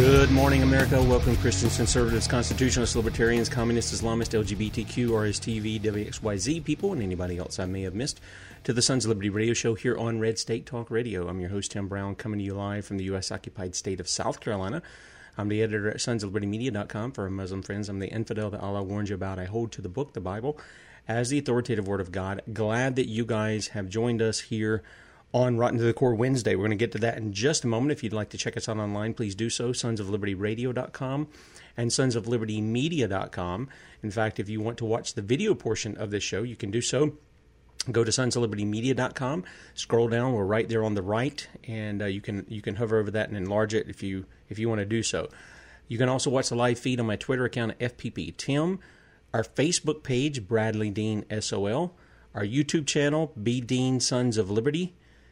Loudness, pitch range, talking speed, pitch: -28 LUFS, 105-125 Hz, 215 wpm, 115 Hz